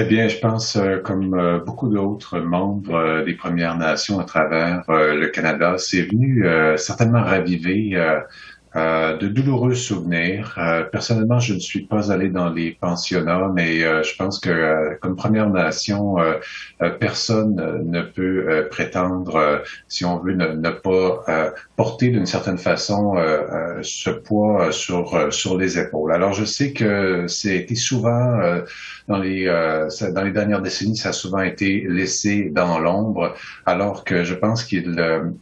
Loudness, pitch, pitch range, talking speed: -20 LUFS, 95 Hz, 85-105 Hz, 175 wpm